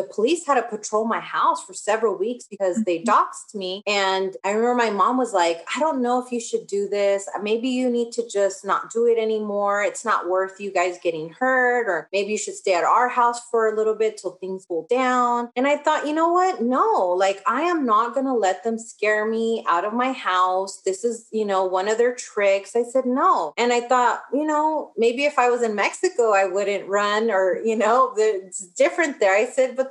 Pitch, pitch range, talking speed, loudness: 225 Hz, 195-250 Hz, 230 wpm, -21 LUFS